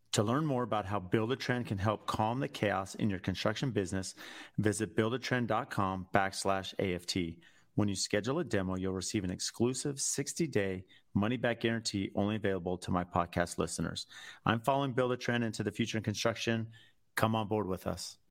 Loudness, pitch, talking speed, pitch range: -34 LUFS, 105 Hz, 175 wpm, 95-115 Hz